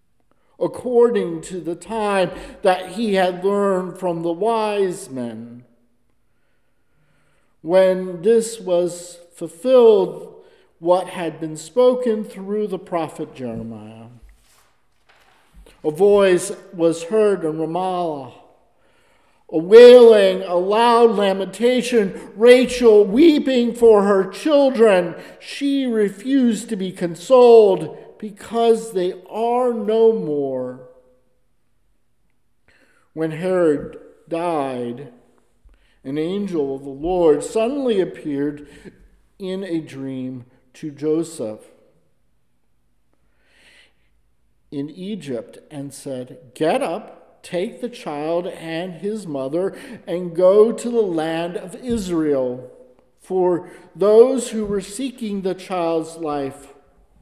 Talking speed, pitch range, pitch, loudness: 95 wpm, 155-220 Hz, 180 Hz, -18 LUFS